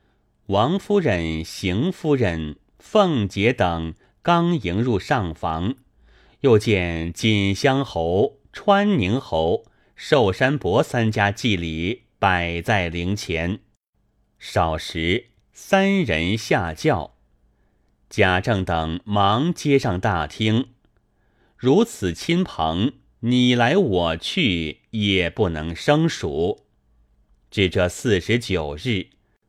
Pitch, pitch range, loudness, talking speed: 105 Hz, 85-125 Hz, -21 LUFS, 135 characters per minute